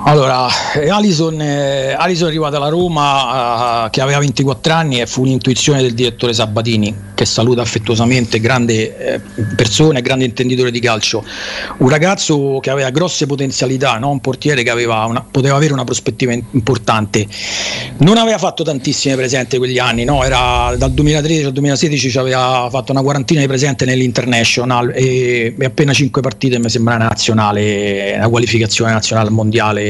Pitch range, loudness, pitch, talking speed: 115-140 Hz, -13 LUFS, 130 Hz, 160 wpm